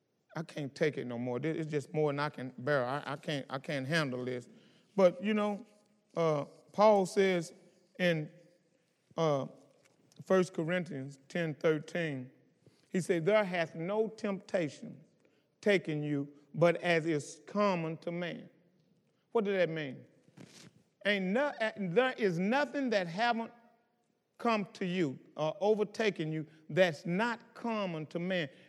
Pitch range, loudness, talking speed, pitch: 155-205 Hz, -33 LUFS, 140 wpm, 175 Hz